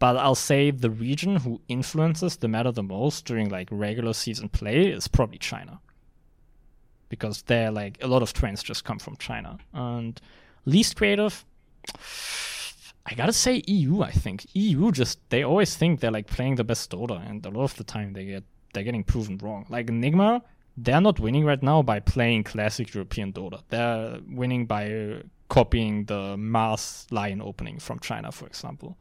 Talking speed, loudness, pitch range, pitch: 180 wpm, -26 LUFS, 105-145 Hz, 120 Hz